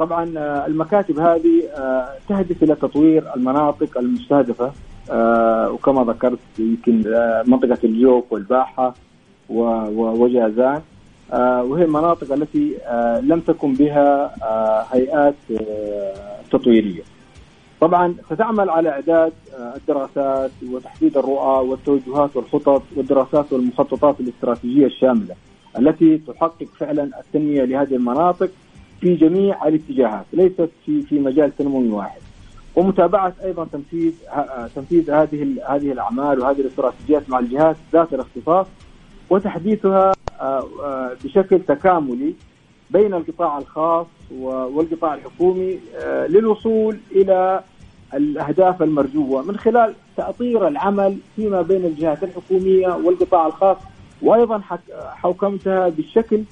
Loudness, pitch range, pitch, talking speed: -18 LUFS, 130-175 Hz, 150 Hz, 95 wpm